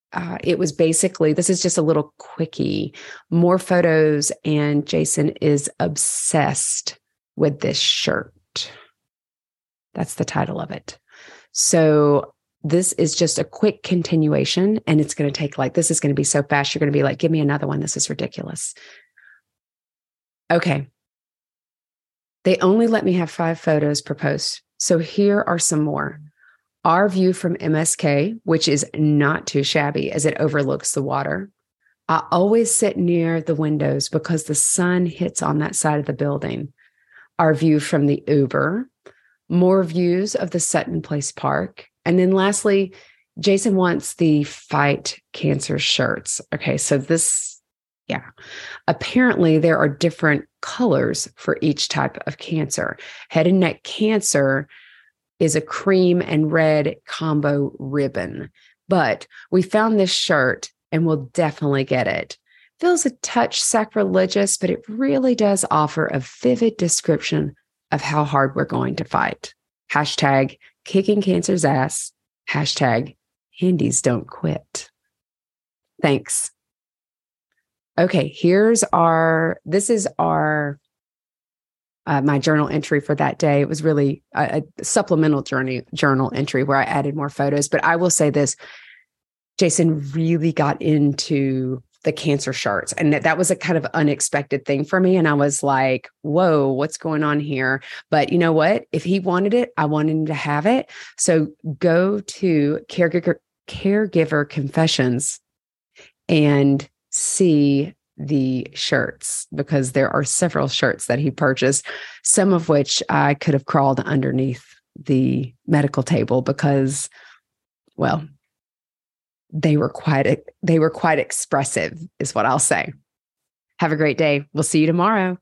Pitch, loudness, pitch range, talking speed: 155 Hz, -19 LUFS, 145-180 Hz, 145 wpm